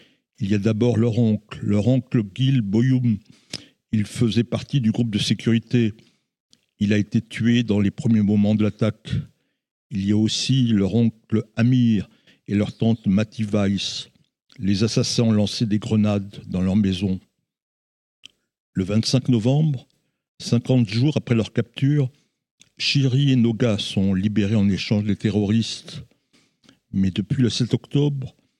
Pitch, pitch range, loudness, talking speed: 115 Hz, 105-125 Hz, -21 LUFS, 145 wpm